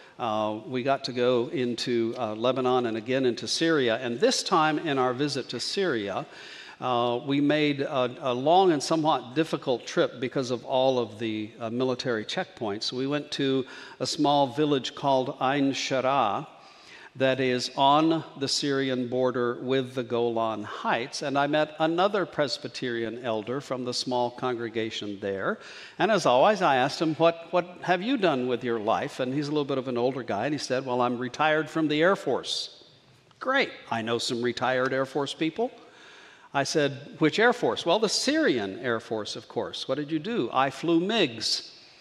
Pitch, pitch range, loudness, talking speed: 130 Hz, 125-150 Hz, -26 LUFS, 185 wpm